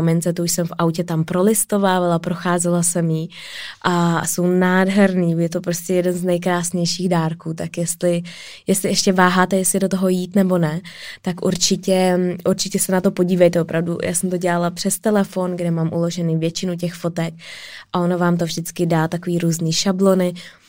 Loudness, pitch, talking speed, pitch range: -19 LUFS, 180 Hz, 175 wpm, 170-185 Hz